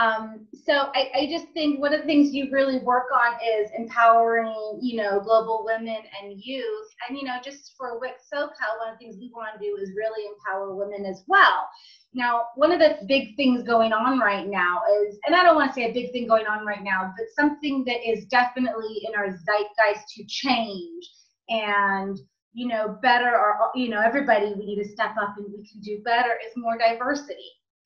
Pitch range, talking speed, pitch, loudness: 210-265 Hz, 205 wpm, 230 Hz, -23 LUFS